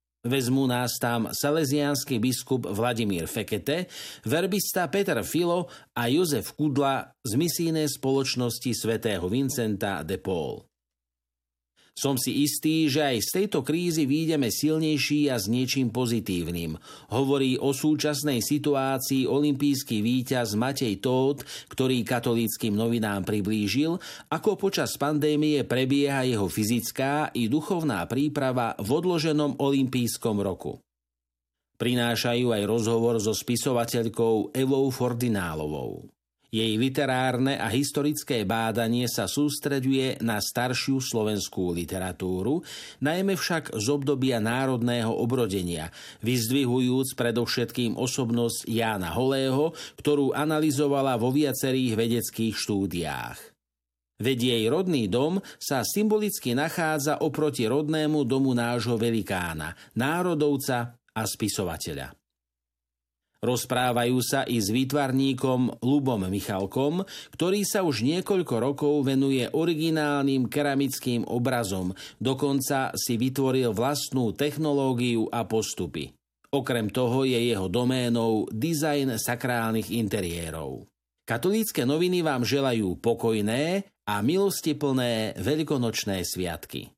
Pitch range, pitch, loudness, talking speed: 115-145 Hz, 125 Hz, -26 LUFS, 105 wpm